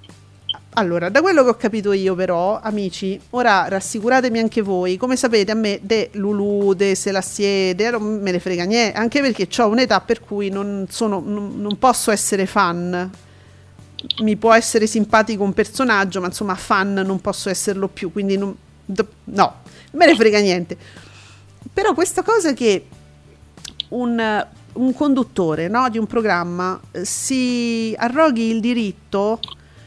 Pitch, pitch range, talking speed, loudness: 205 Hz, 185-230 Hz, 145 wpm, -18 LUFS